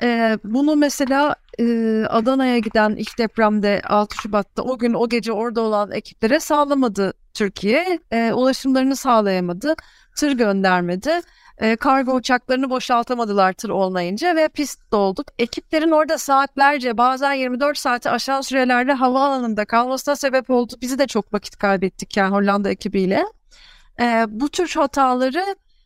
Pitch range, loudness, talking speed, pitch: 215-280 Hz, -19 LUFS, 130 wpm, 245 Hz